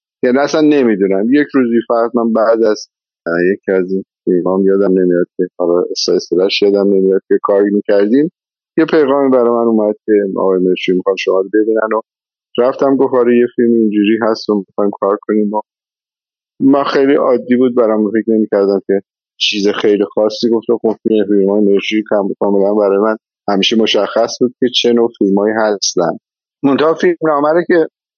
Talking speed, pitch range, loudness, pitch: 165 wpm, 100-120 Hz, -13 LUFS, 110 Hz